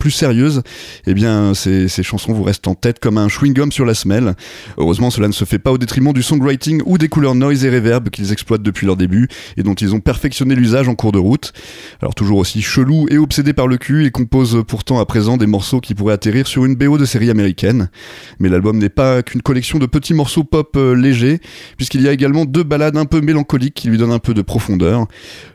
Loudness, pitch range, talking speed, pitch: -14 LUFS, 105-140 Hz, 235 wpm, 125 Hz